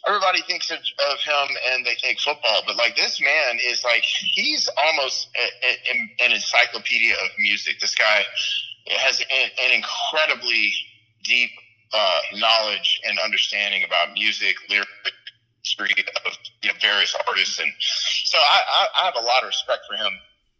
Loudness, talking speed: -19 LUFS, 165 wpm